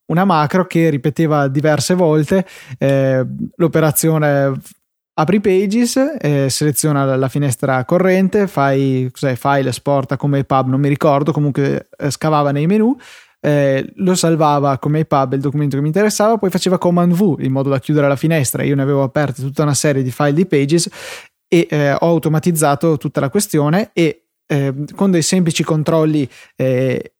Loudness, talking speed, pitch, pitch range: -15 LUFS, 160 wpm, 150 Hz, 140-170 Hz